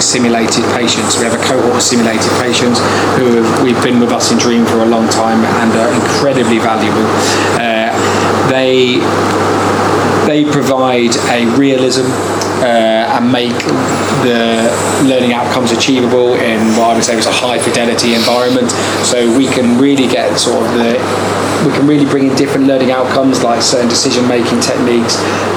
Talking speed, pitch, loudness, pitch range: 160 wpm, 120 Hz, -10 LUFS, 115-130 Hz